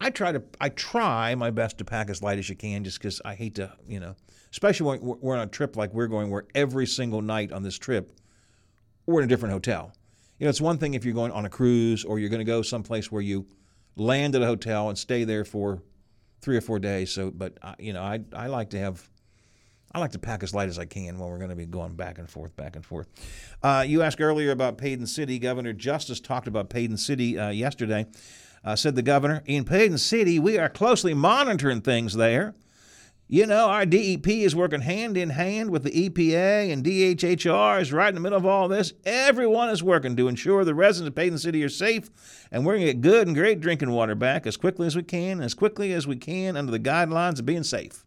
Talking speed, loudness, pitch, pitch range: 240 wpm, -25 LUFS, 120 Hz, 105-165 Hz